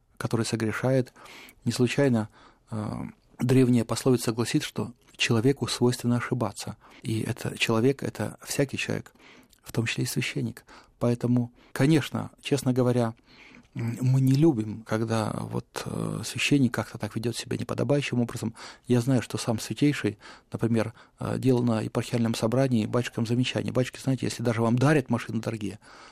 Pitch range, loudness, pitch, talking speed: 115-130 Hz, -27 LUFS, 120 Hz, 140 wpm